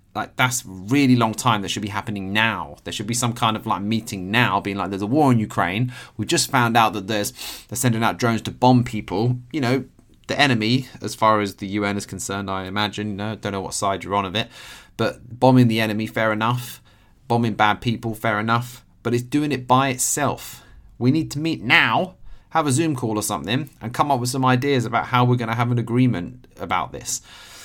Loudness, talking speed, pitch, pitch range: -21 LUFS, 230 wpm, 115 Hz, 105-125 Hz